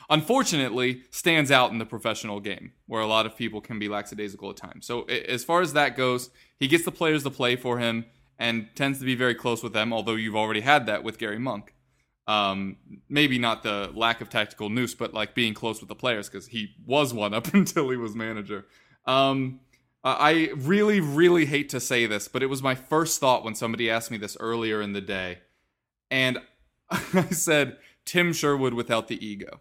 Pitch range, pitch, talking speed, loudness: 110-140 Hz, 125 Hz, 205 wpm, -25 LUFS